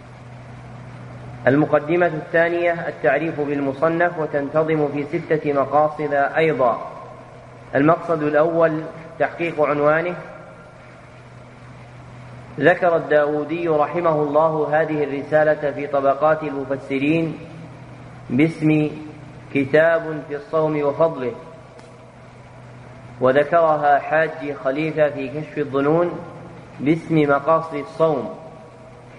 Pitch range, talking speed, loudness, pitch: 135-160 Hz, 75 wpm, -19 LUFS, 150 Hz